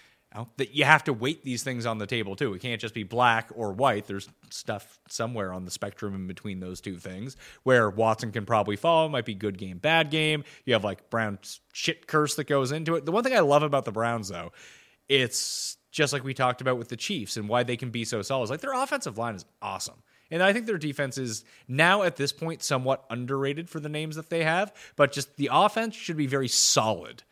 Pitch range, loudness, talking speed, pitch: 115-155 Hz, -27 LUFS, 235 wpm, 130 Hz